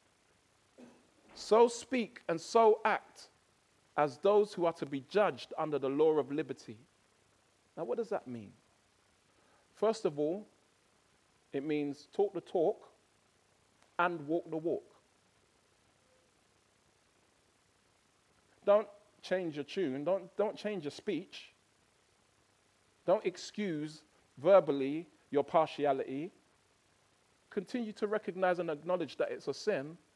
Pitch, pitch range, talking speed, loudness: 175 Hz, 150-210 Hz, 115 wpm, -34 LUFS